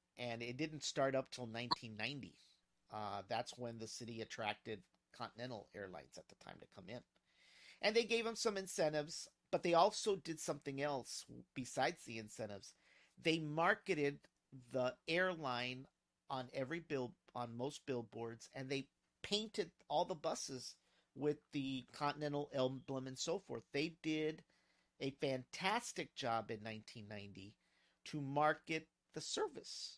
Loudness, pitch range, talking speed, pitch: -42 LUFS, 115-160 Hz, 145 wpm, 135 Hz